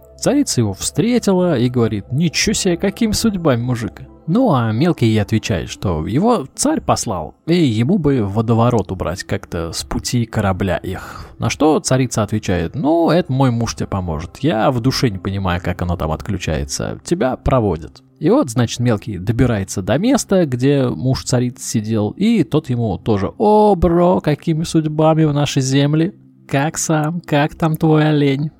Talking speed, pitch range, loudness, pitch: 165 wpm, 105-155 Hz, -17 LUFS, 130 Hz